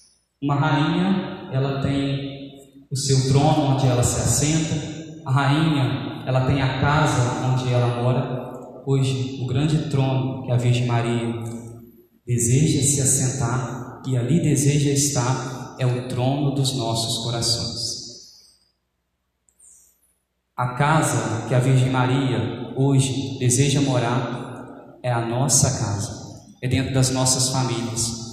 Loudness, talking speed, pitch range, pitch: -21 LUFS, 125 wpm, 120-140 Hz, 130 Hz